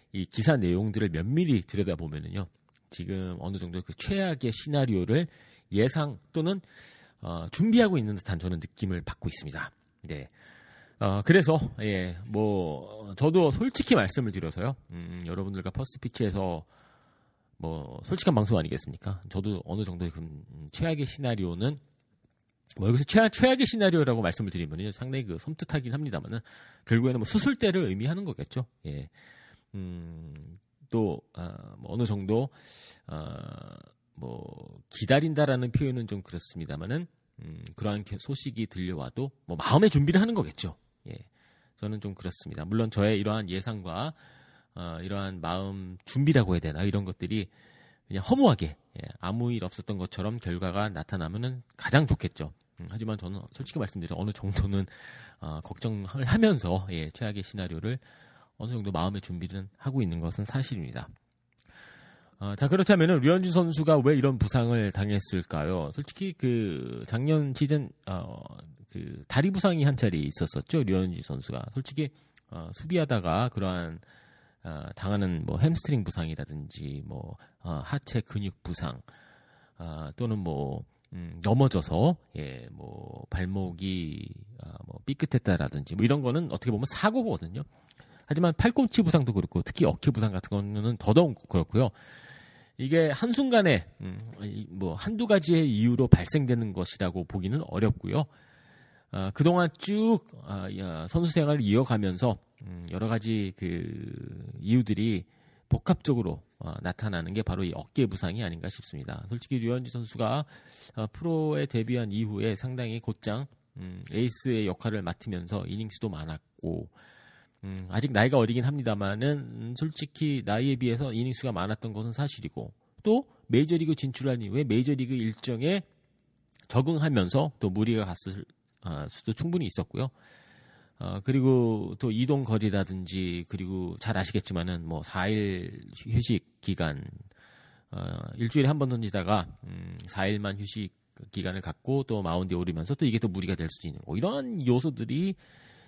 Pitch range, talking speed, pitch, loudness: 95-140 Hz, 315 characters per minute, 115 Hz, -29 LUFS